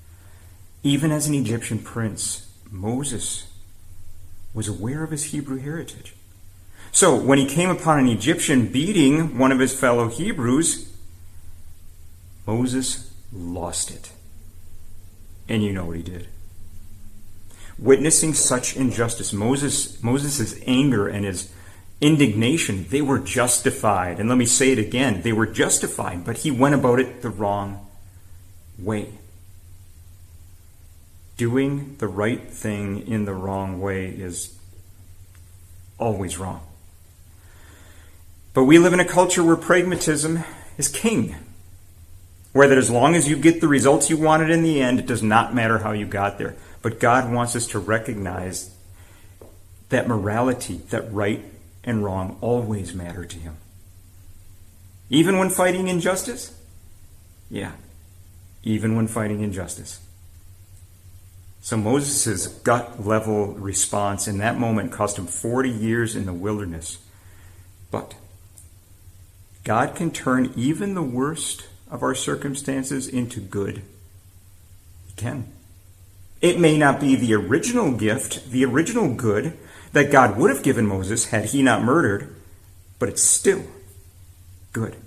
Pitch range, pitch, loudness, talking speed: 90-125 Hz, 100 Hz, -21 LUFS, 130 wpm